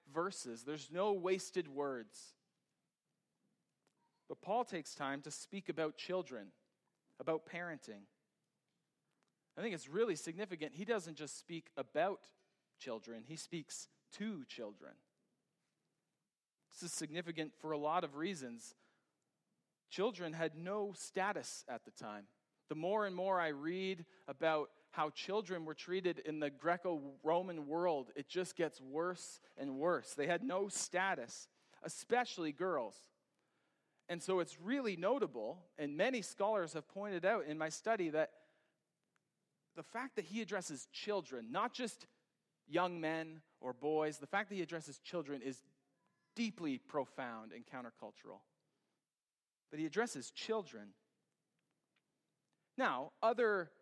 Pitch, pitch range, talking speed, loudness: 165 Hz, 150-190 Hz, 130 wpm, -41 LUFS